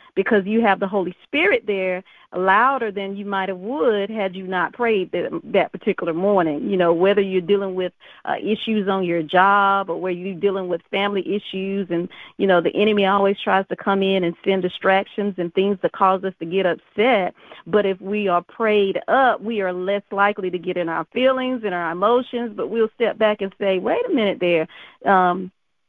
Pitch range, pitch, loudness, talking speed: 185-205 Hz, 195 Hz, -20 LUFS, 205 wpm